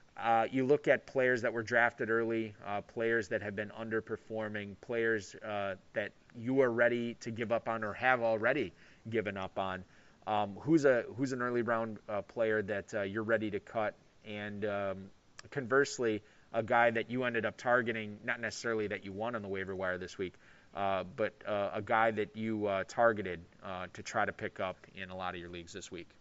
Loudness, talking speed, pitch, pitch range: -34 LUFS, 205 wpm, 110 Hz, 100-115 Hz